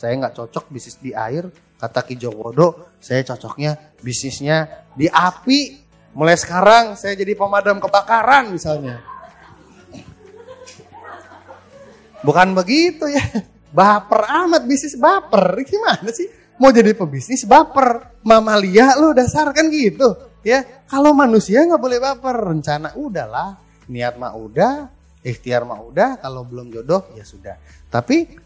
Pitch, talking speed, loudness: 200 Hz, 125 wpm, -16 LUFS